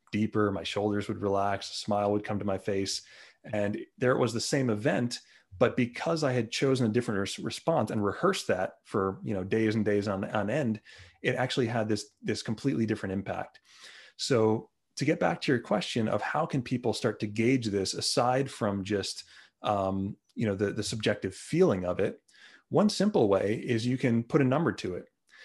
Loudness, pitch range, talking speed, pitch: -29 LUFS, 100-125 Hz, 200 wpm, 110 Hz